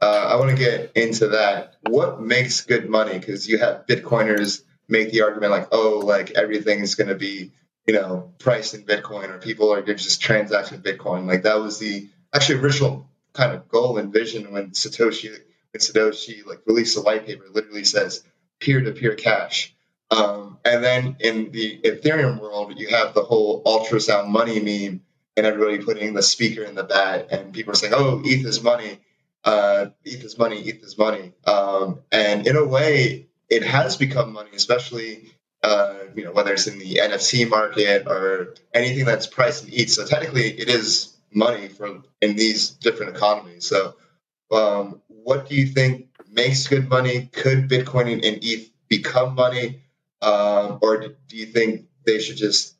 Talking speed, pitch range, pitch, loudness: 175 wpm, 105-125 Hz, 110 Hz, -20 LUFS